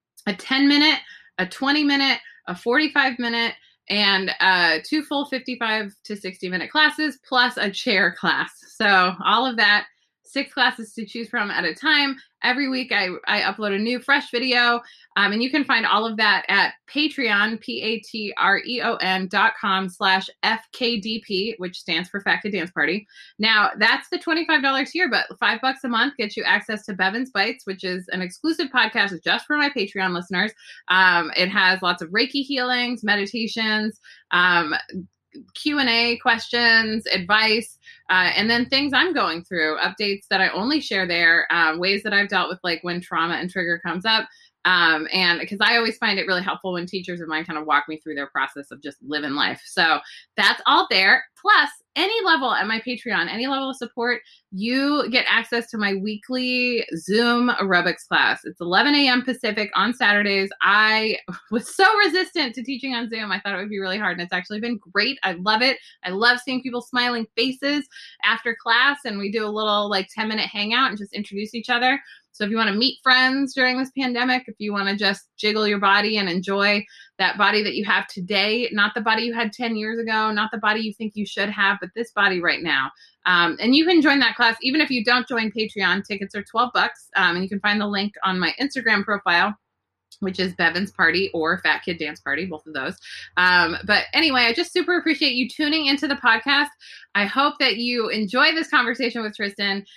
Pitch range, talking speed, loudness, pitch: 190-250 Hz, 200 wpm, -20 LUFS, 220 Hz